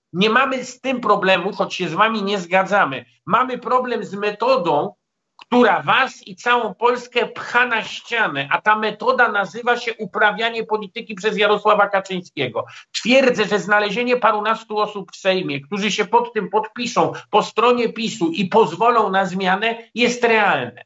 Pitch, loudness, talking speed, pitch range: 215 Hz, -18 LUFS, 160 wpm, 200-235 Hz